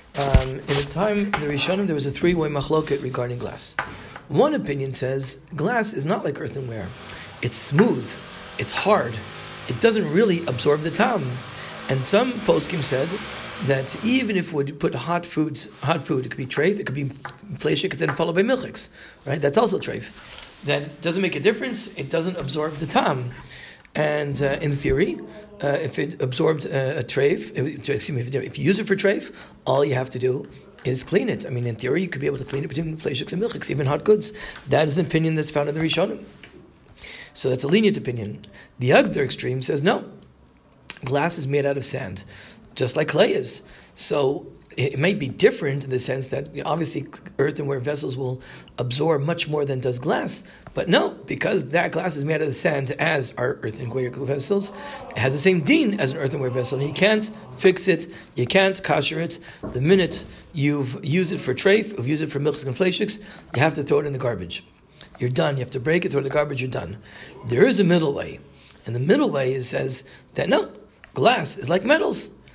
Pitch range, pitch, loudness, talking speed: 130-175 Hz, 145 Hz, -23 LUFS, 210 wpm